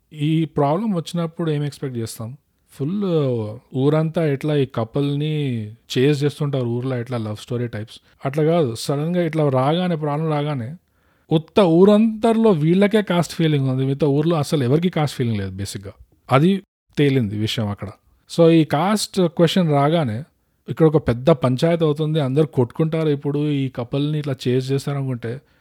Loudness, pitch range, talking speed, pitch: -20 LUFS, 130-165 Hz, 145 wpm, 145 Hz